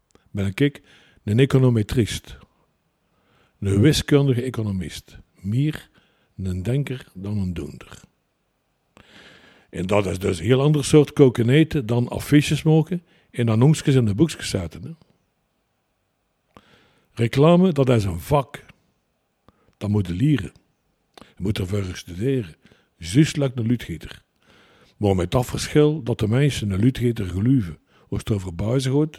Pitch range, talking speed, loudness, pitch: 100-140 Hz, 130 wpm, -21 LUFS, 120 Hz